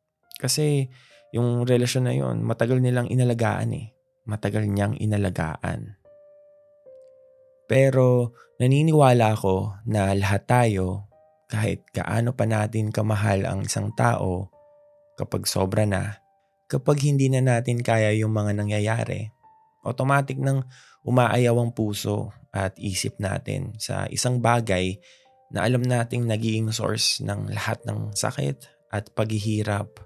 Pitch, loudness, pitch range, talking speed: 120 Hz, -24 LUFS, 105-135 Hz, 120 wpm